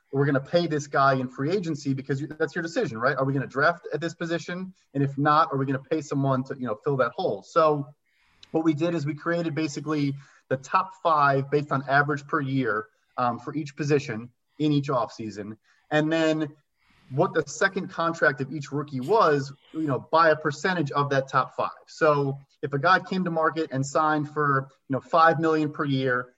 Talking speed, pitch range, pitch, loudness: 215 wpm, 135-160 Hz, 150 Hz, -25 LUFS